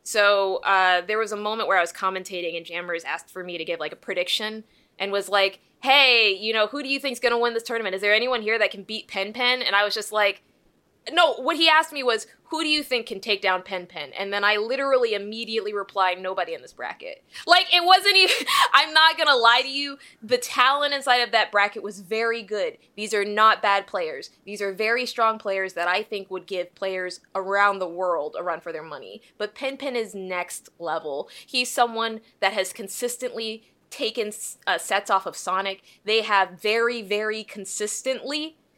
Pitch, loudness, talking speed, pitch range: 215 Hz, -22 LUFS, 215 wpm, 195-250 Hz